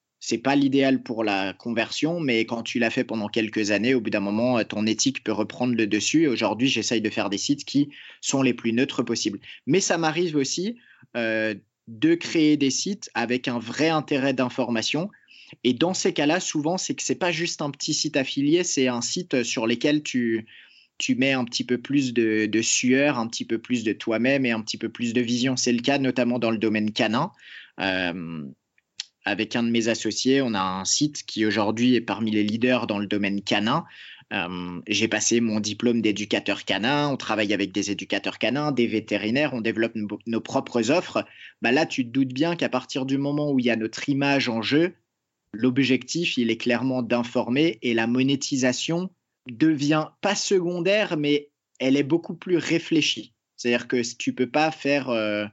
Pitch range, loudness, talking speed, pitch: 110-145 Hz, -24 LUFS, 200 wpm, 125 Hz